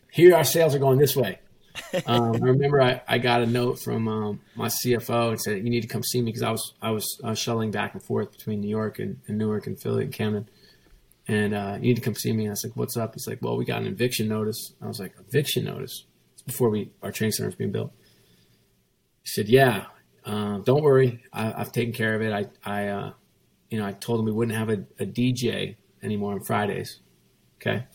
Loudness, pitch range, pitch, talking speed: -25 LUFS, 105-125 Hz, 110 Hz, 240 wpm